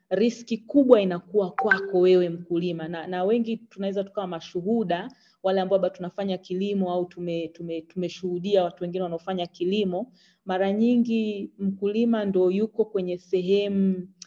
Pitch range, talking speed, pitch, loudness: 180-205 Hz, 135 wpm, 190 Hz, -25 LUFS